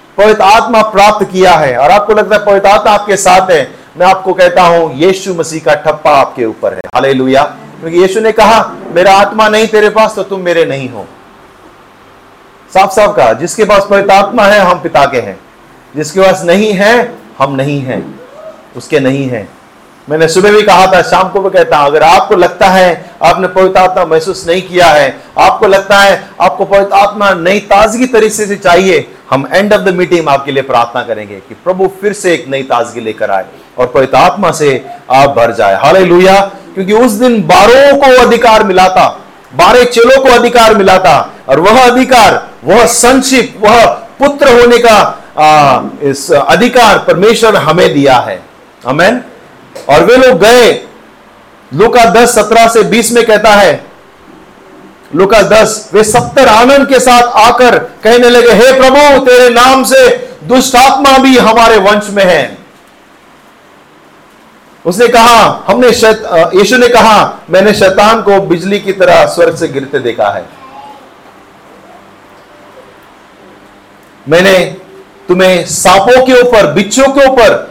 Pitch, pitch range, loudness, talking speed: 200 Hz, 175-230 Hz, -6 LUFS, 160 wpm